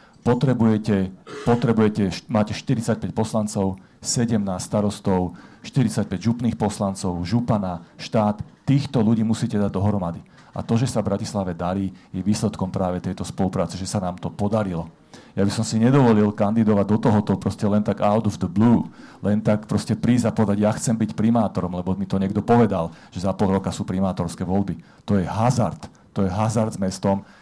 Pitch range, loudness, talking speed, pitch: 95-110 Hz, -22 LUFS, 175 wpm, 105 Hz